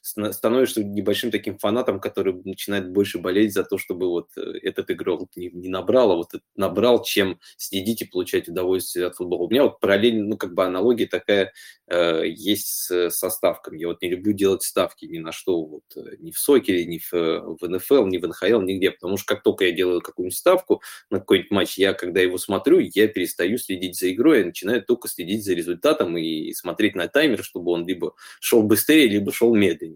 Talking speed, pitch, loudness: 200 wpm, 100 Hz, -22 LUFS